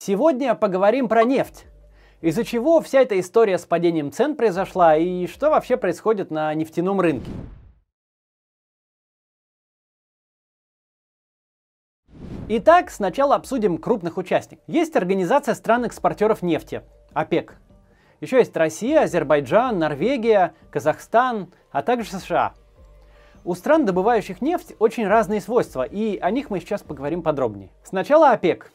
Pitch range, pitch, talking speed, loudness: 170-240 Hz, 200 Hz, 115 wpm, -20 LUFS